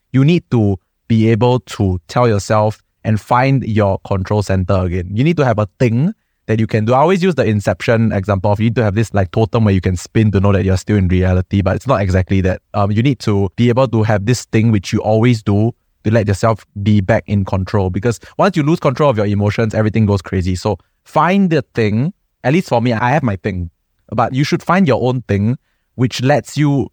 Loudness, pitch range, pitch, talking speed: -15 LUFS, 100-125 Hz, 110 Hz, 240 wpm